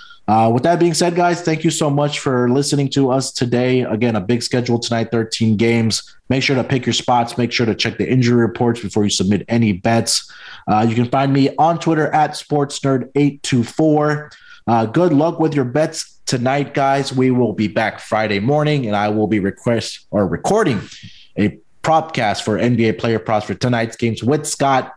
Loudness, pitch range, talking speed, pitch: -17 LUFS, 115-145 Hz, 190 wpm, 125 Hz